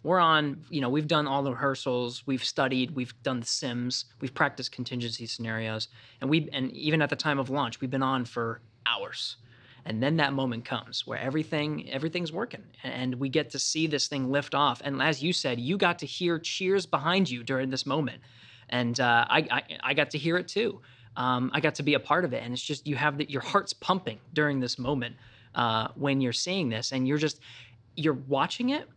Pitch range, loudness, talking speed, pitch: 125-150 Hz, -29 LUFS, 220 wpm, 135 Hz